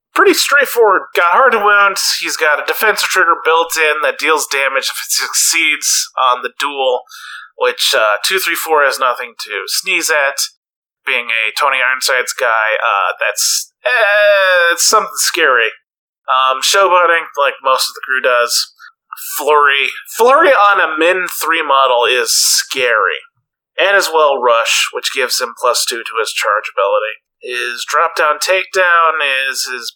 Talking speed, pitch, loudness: 160 wpm, 200 Hz, -12 LUFS